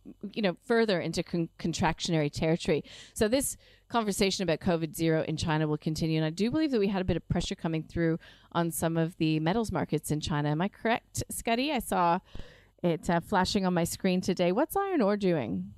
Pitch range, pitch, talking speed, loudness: 160-200 Hz, 170 Hz, 210 wpm, -29 LUFS